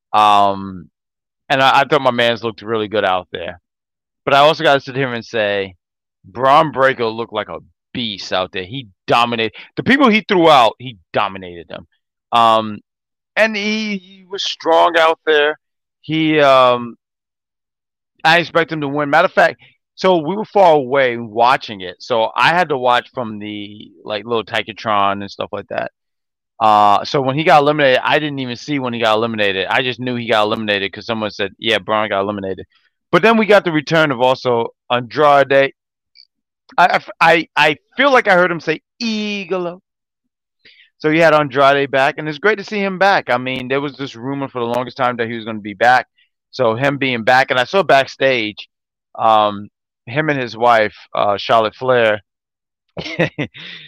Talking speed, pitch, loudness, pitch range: 185 wpm, 130 Hz, -15 LUFS, 110-155 Hz